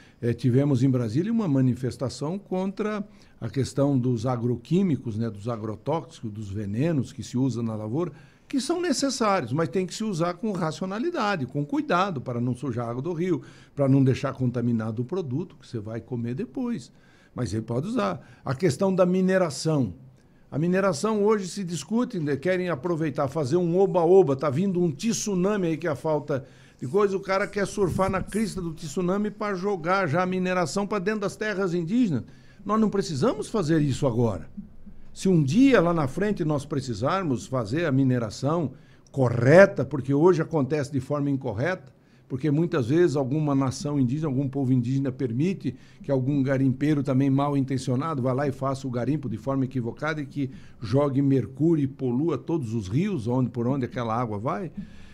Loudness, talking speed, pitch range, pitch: -25 LUFS, 175 wpm, 130-185 Hz, 145 Hz